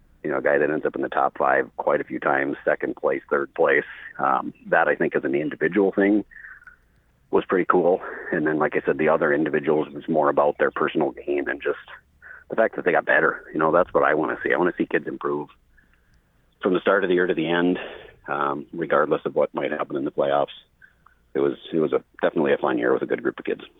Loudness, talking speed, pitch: -23 LUFS, 250 wpm, 105 Hz